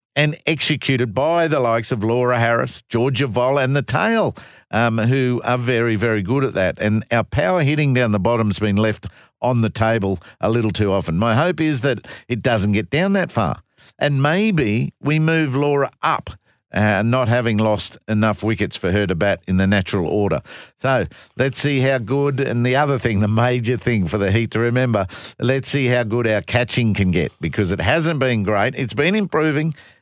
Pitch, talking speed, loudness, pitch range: 120 Hz, 200 wpm, -19 LUFS, 105-135 Hz